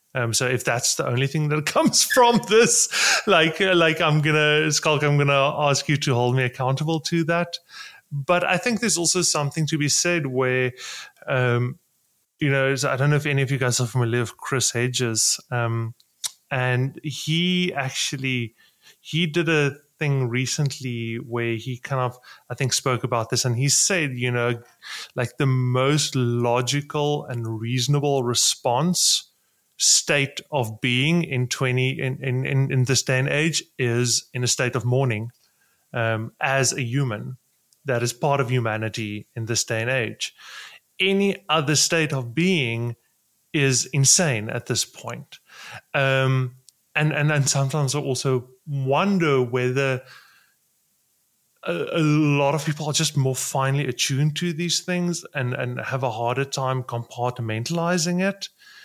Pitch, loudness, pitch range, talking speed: 135 Hz, -22 LUFS, 125-155 Hz, 160 wpm